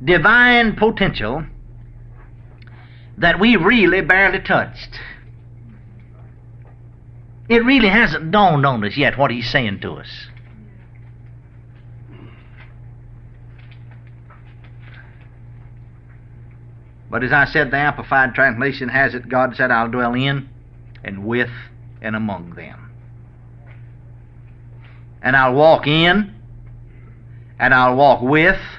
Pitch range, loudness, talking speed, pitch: 120-130 Hz, -15 LUFS, 95 wpm, 120 Hz